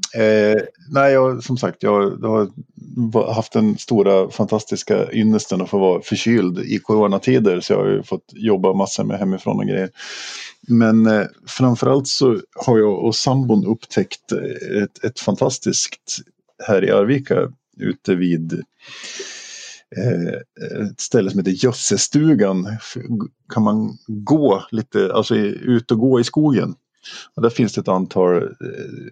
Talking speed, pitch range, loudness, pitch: 140 wpm, 100-125 Hz, -18 LUFS, 110 Hz